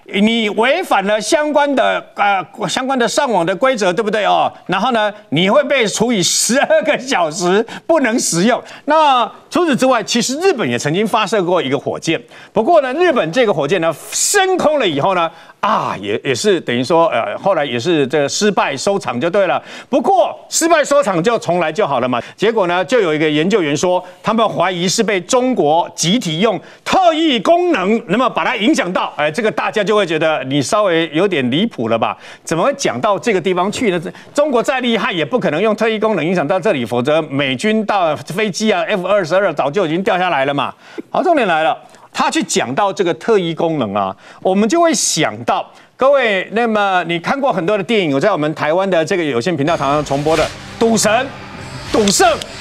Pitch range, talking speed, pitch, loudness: 175-255 Hz, 300 characters per minute, 210 Hz, -15 LUFS